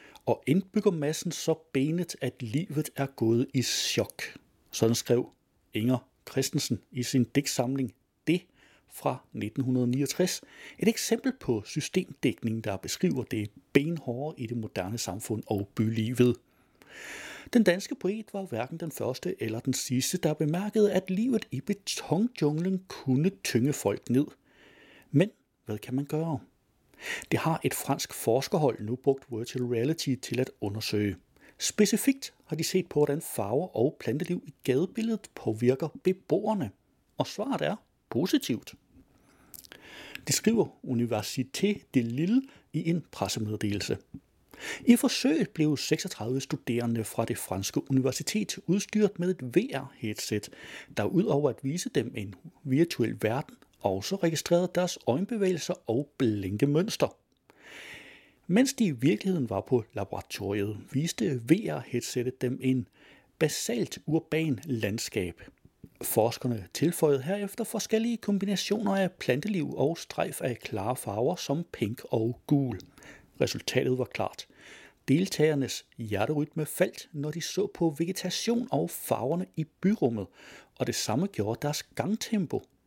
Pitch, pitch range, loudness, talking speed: 145 Hz, 120-185 Hz, -30 LUFS, 130 wpm